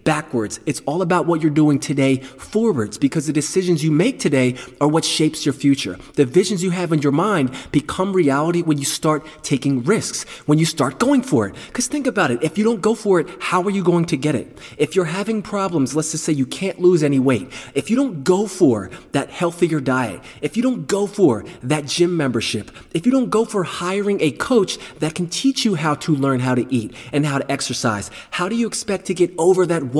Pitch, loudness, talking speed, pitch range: 155 Hz, -19 LUFS, 230 wpm, 140-185 Hz